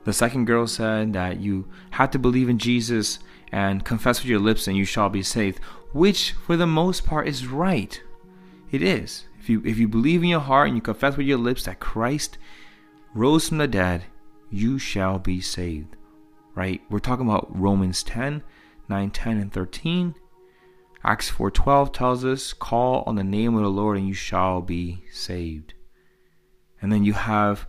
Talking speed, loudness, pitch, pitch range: 185 wpm, -23 LUFS, 110 Hz, 95-135 Hz